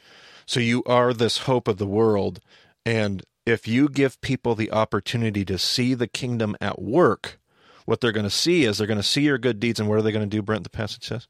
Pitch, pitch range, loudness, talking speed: 115 Hz, 105-125 Hz, -23 LUFS, 240 wpm